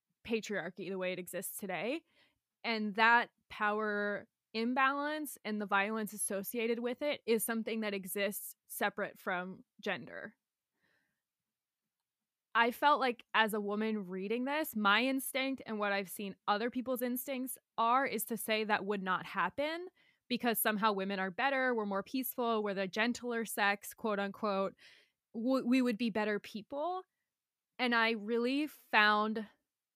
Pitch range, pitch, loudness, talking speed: 205-245 Hz, 220 Hz, -34 LUFS, 140 wpm